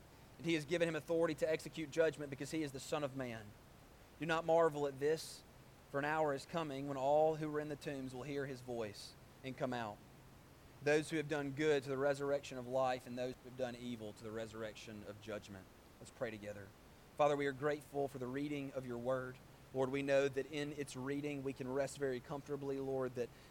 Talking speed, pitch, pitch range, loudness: 220 wpm, 140 Hz, 125-150 Hz, -40 LUFS